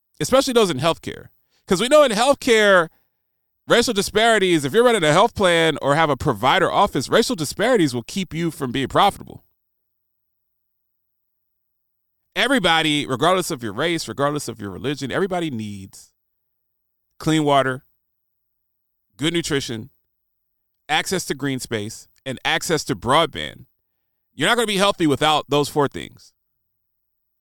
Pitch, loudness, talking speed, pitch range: 150 Hz, -19 LUFS, 140 wpm, 120-185 Hz